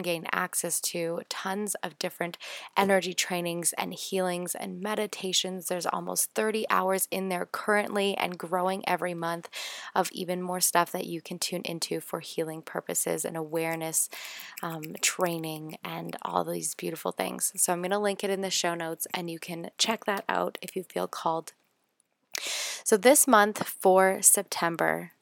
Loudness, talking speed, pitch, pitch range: -28 LUFS, 165 wpm, 180 Hz, 170-195 Hz